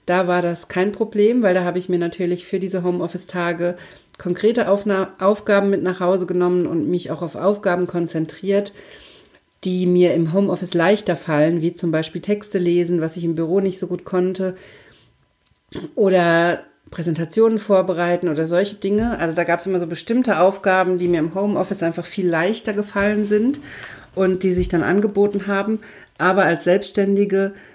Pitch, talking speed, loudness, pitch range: 185 Hz, 170 wpm, -19 LUFS, 175-200 Hz